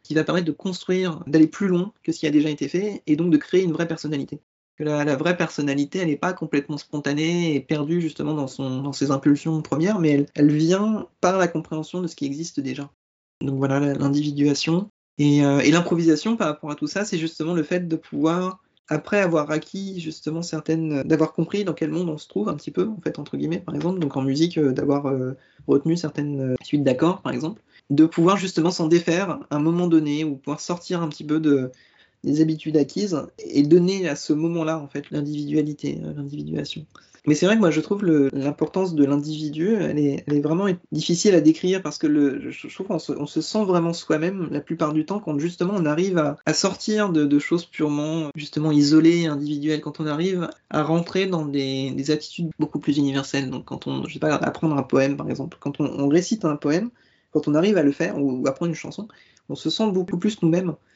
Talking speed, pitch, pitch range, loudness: 220 wpm, 155 Hz, 145-175 Hz, -22 LUFS